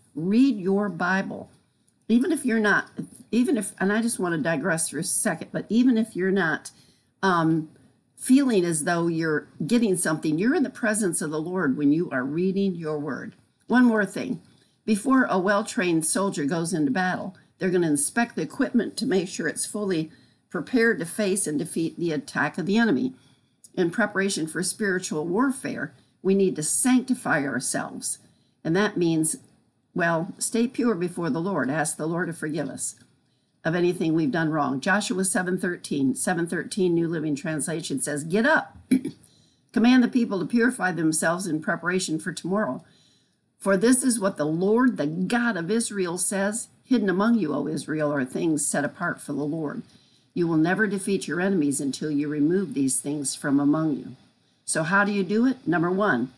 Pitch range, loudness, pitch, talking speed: 160-220 Hz, -24 LUFS, 185 Hz, 185 wpm